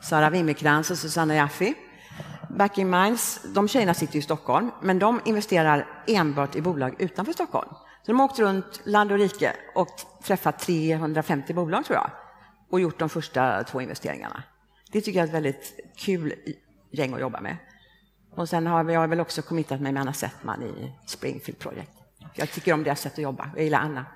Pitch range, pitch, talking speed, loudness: 150-190 Hz, 165 Hz, 185 wpm, -25 LUFS